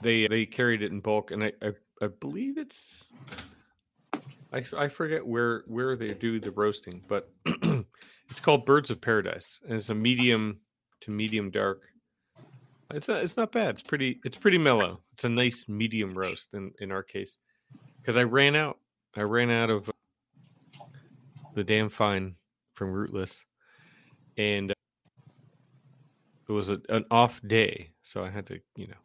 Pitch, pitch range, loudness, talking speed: 115 Hz, 105-140 Hz, -28 LUFS, 165 wpm